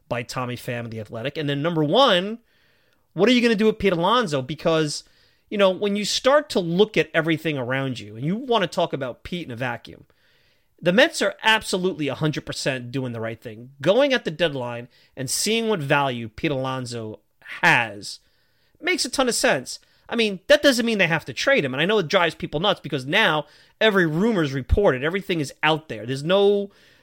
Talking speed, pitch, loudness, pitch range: 210 wpm, 165 Hz, -22 LUFS, 135-210 Hz